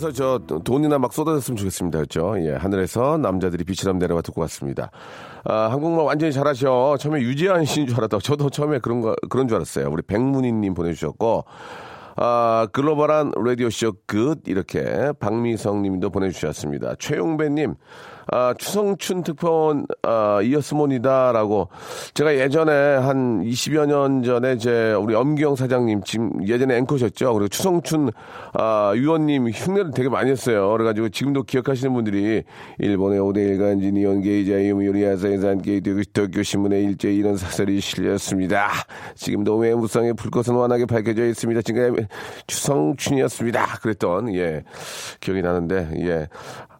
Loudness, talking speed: -21 LUFS, 365 characters per minute